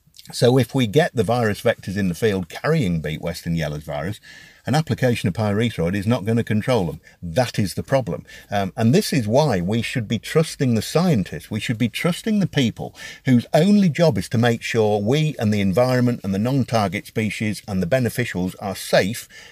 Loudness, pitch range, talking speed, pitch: -21 LUFS, 105-130 Hz, 205 wpm, 115 Hz